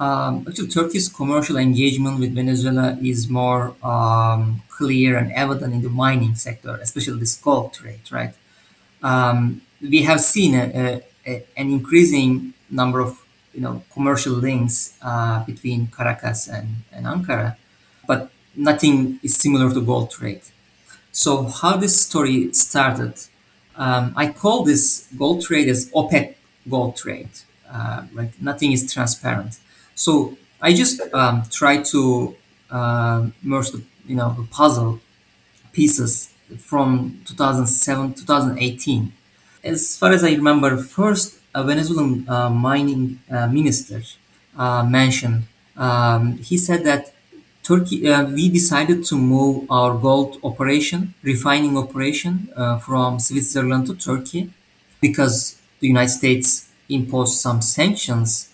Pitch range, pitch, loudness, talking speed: 120-145 Hz, 130 Hz, -16 LUFS, 130 wpm